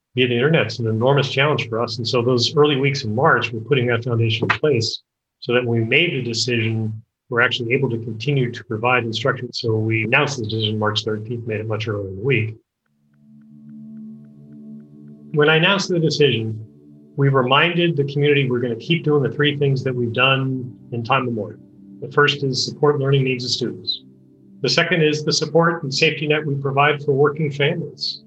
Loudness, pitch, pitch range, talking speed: -19 LUFS, 125 Hz, 110-145 Hz, 205 wpm